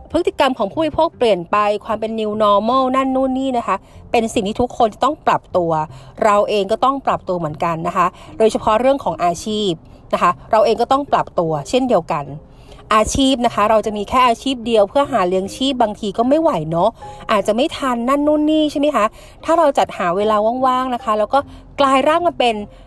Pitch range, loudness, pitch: 205-270 Hz, -17 LUFS, 230 Hz